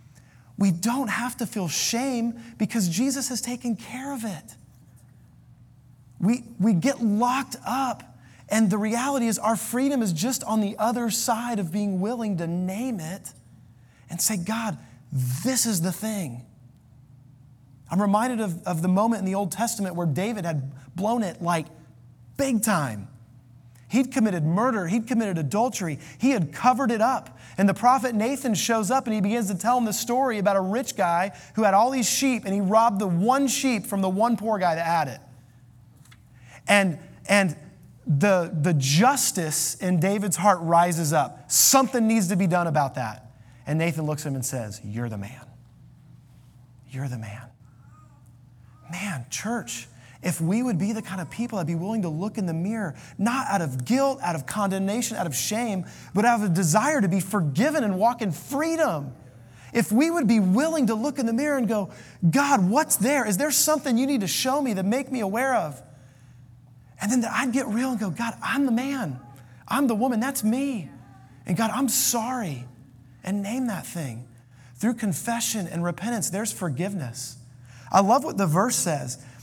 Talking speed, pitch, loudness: 185 wpm, 195 Hz, -24 LUFS